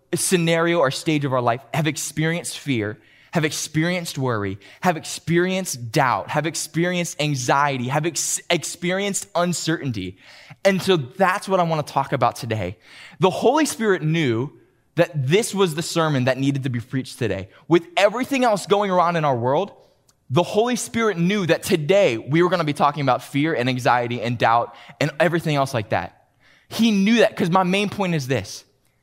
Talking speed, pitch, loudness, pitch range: 180 wpm, 160 Hz, -21 LUFS, 130-180 Hz